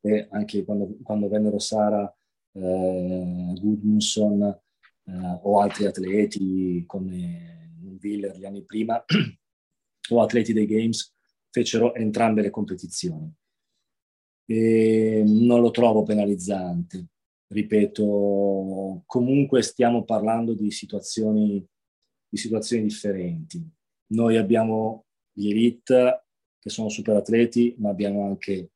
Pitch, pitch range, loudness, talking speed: 105 Hz, 100-115 Hz, -23 LUFS, 105 wpm